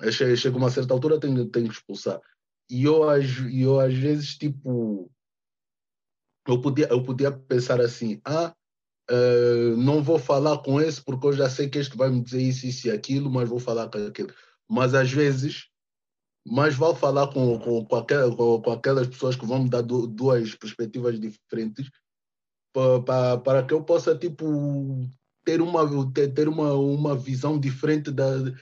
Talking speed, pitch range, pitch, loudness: 180 wpm, 125-145 Hz, 130 Hz, -24 LUFS